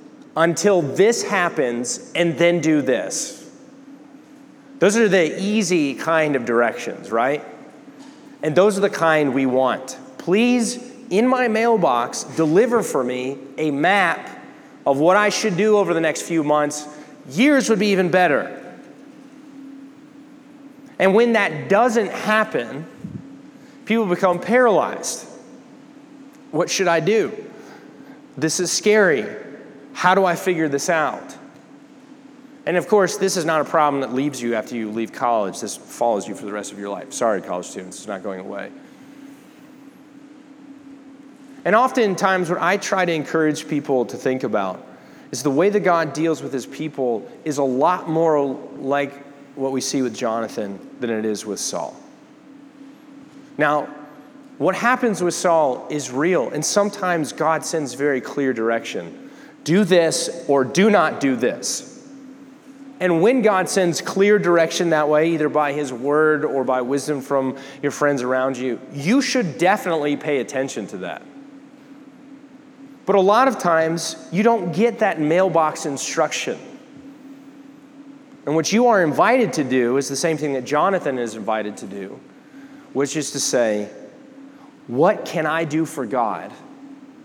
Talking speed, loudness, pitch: 150 wpm, -20 LUFS, 185 Hz